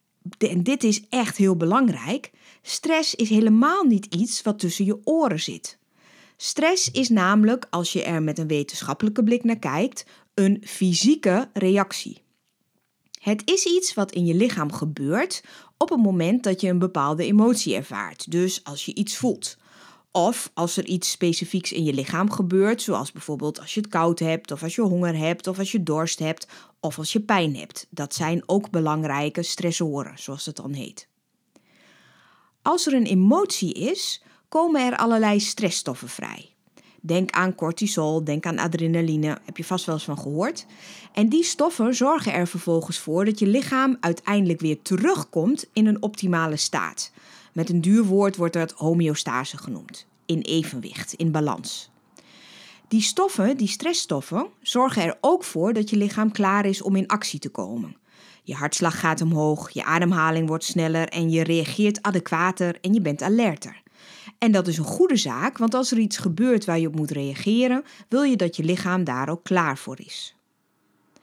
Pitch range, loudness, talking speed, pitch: 165-220 Hz, -23 LUFS, 175 wpm, 185 Hz